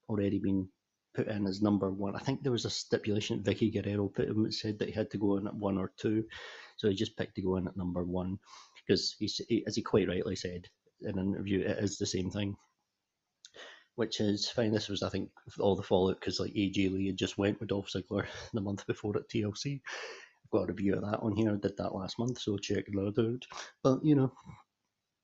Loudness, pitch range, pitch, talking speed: -33 LUFS, 95-110 Hz, 100 Hz, 240 wpm